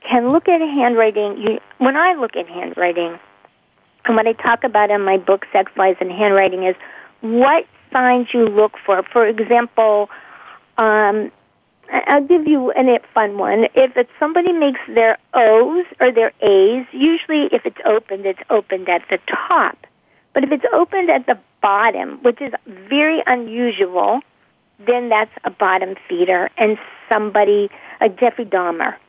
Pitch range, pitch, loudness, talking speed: 205-265 Hz, 225 Hz, -16 LUFS, 155 wpm